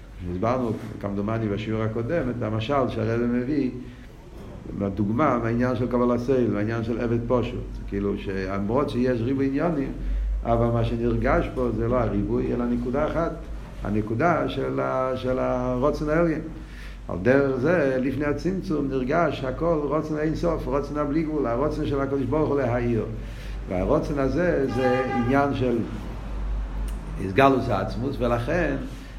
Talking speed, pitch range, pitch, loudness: 135 wpm, 115-140 Hz, 125 Hz, -25 LUFS